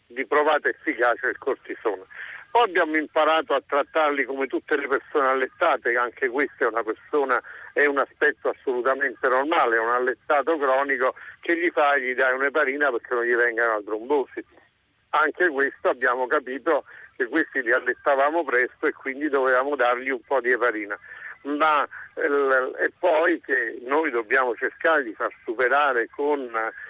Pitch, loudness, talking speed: 145 Hz, -23 LUFS, 155 wpm